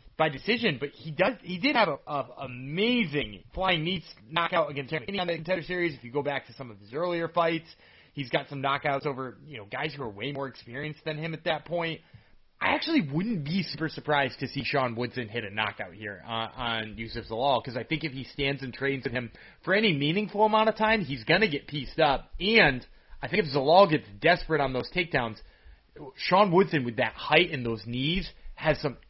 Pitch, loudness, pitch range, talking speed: 145 Hz, -28 LUFS, 125-170 Hz, 220 wpm